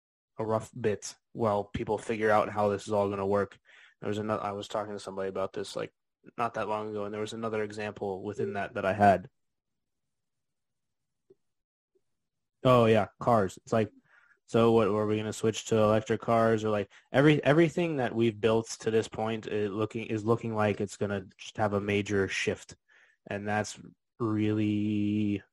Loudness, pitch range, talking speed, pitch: -29 LUFS, 105-115 Hz, 180 wpm, 105 Hz